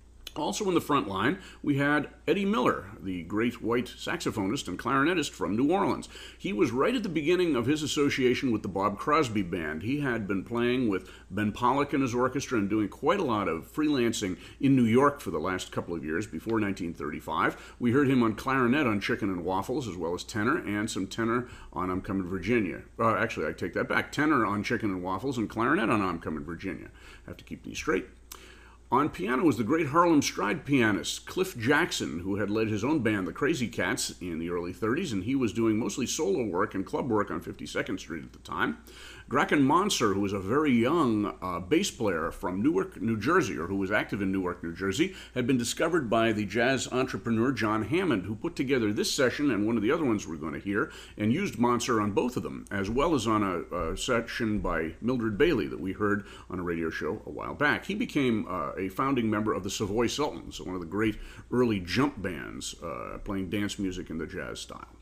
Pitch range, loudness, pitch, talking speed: 95-125 Hz, -29 LUFS, 110 Hz, 220 wpm